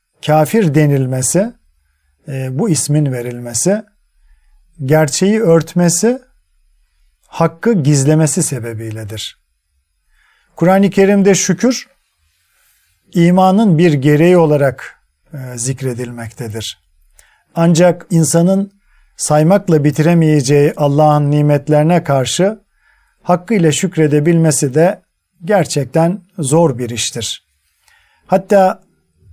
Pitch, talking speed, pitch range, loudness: 155 Hz, 70 wpm, 125-180 Hz, -13 LUFS